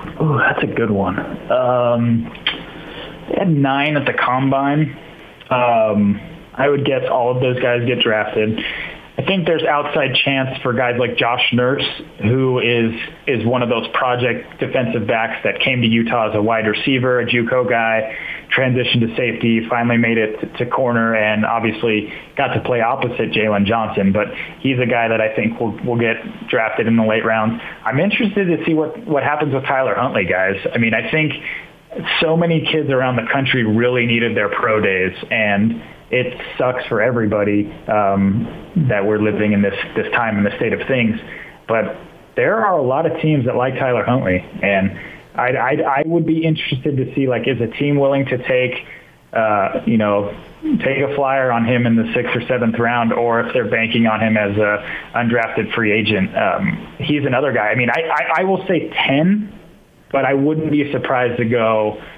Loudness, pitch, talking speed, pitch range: -17 LUFS, 125 Hz, 190 wpm, 110-140 Hz